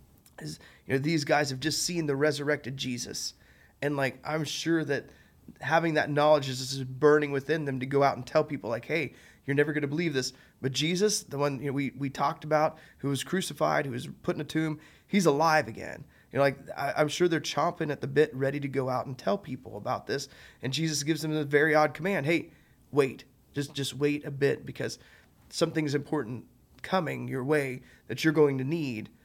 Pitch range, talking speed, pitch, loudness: 130-155 Hz, 215 wpm, 145 Hz, -29 LUFS